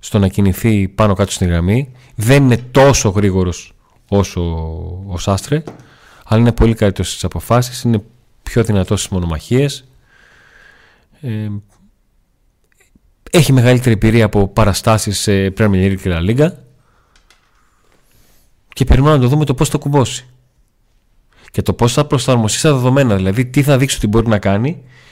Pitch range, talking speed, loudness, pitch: 100-130 Hz, 140 wpm, -14 LUFS, 110 Hz